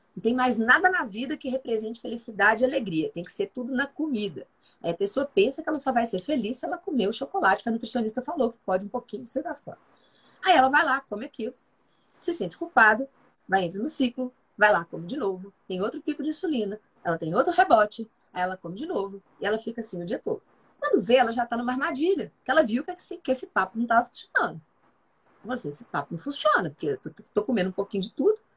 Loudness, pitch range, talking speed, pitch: -26 LUFS, 205-290 Hz, 245 wpm, 245 Hz